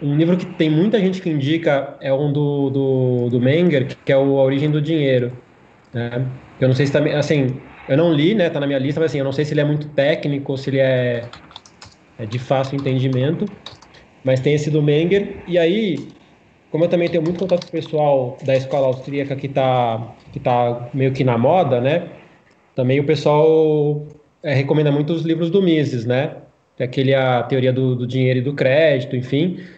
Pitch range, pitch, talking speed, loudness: 130-155 Hz, 140 Hz, 210 wpm, -18 LUFS